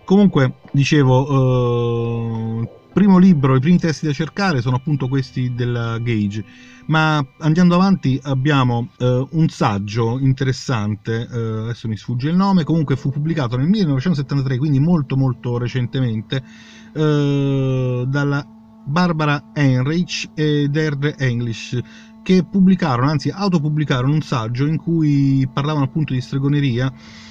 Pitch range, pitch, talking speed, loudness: 125-155 Hz, 140 Hz, 125 wpm, -18 LUFS